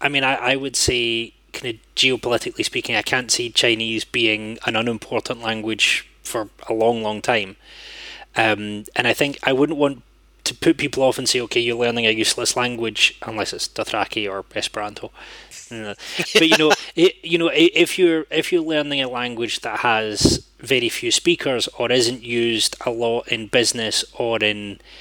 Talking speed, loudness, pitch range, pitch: 180 wpm, -19 LUFS, 110-145 Hz, 120 Hz